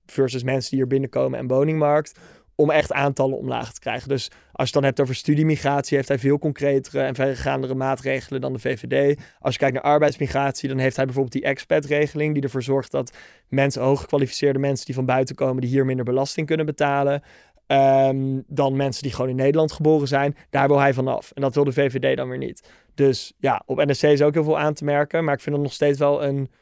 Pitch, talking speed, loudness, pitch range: 140 Hz, 225 wpm, -21 LUFS, 135-145 Hz